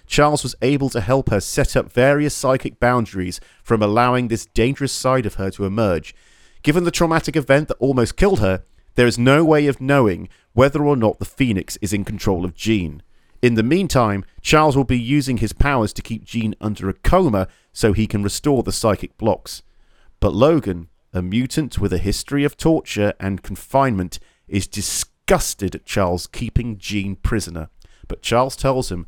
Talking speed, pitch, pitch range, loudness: 180 wpm, 115 Hz, 100-135 Hz, -19 LUFS